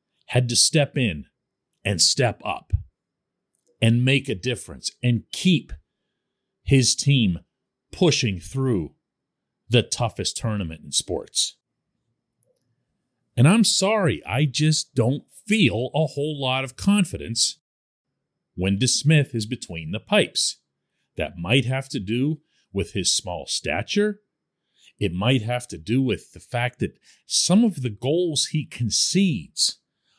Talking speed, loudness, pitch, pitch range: 125 wpm, -22 LUFS, 130 Hz, 115-155 Hz